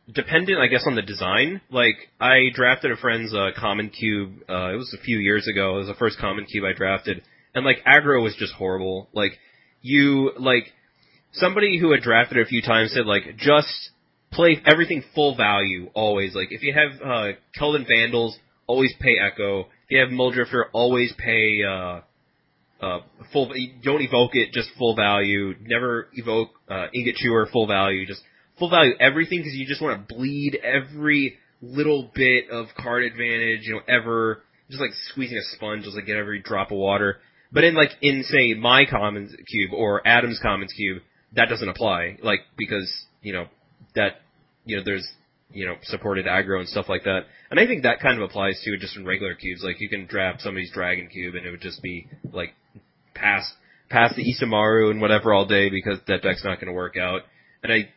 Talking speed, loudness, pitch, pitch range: 200 wpm, -21 LUFS, 115 Hz, 100-130 Hz